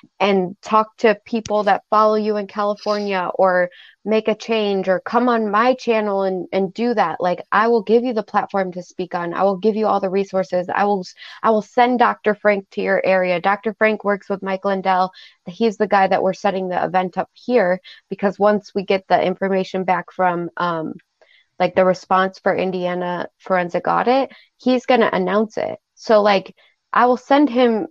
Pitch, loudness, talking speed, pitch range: 200 Hz, -19 LUFS, 200 wpm, 185-220 Hz